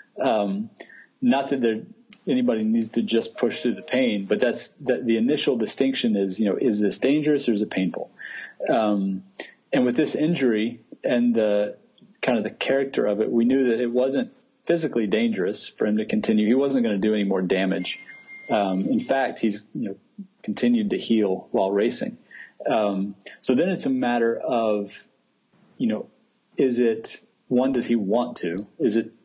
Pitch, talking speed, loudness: 120 Hz, 185 wpm, -23 LUFS